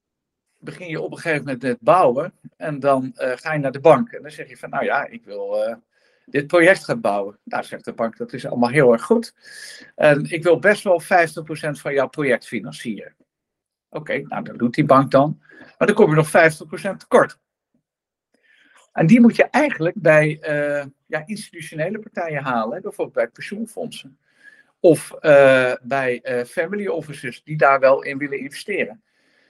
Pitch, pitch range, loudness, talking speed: 155 Hz, 135-185 Hz, -19 LUFS, 190 wpm